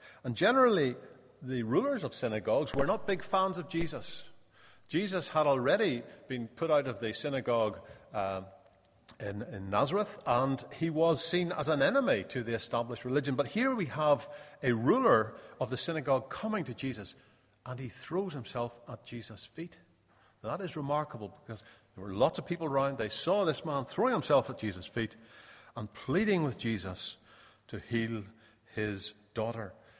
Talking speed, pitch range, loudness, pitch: 165 wpm, 110-160 Hz, -32 LUFS, 130 Hz